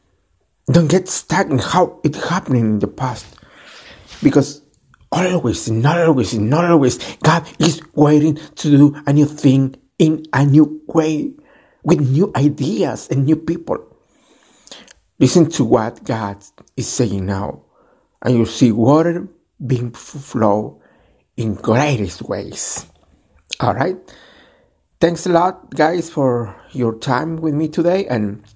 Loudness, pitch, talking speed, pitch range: -17 LUFS, 145 Hz, 130 wpm, 120-165 Hz